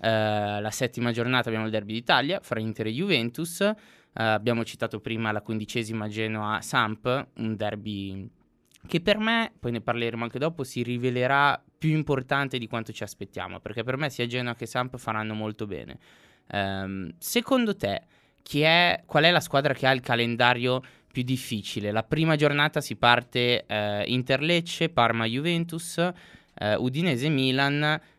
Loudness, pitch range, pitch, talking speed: -26 LUFS, 110-145 Hz, 120 Hz, 155 wpm